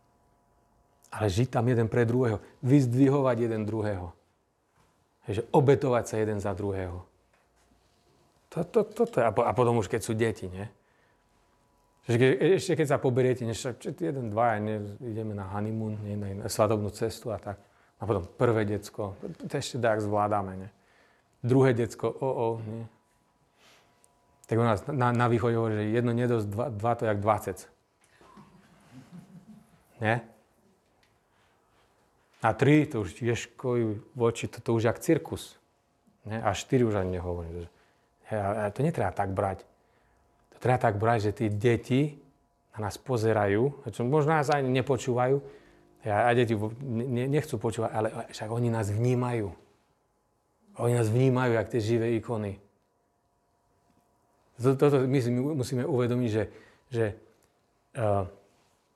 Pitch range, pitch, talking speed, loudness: 105-130 Hz, 115 Hz, 140 wpm, -28 LUFS